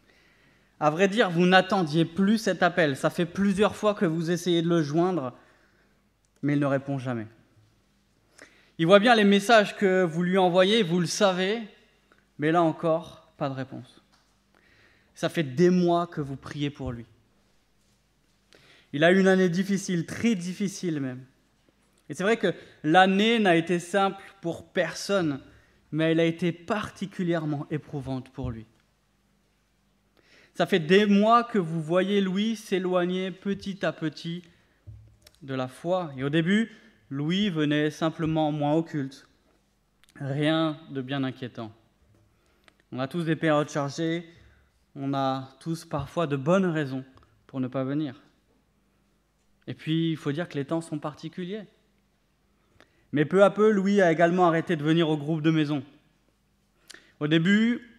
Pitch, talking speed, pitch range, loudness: 165 Hz, 150 wpm, 145-190 Hz, -25 LUFS